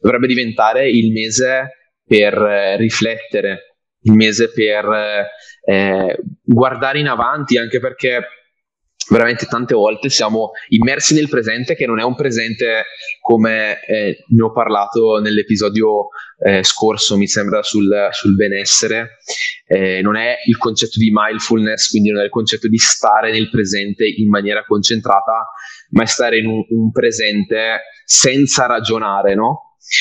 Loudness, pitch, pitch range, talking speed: -14 LUFS, 110 Hz, 105-120 Hz, 140 wpm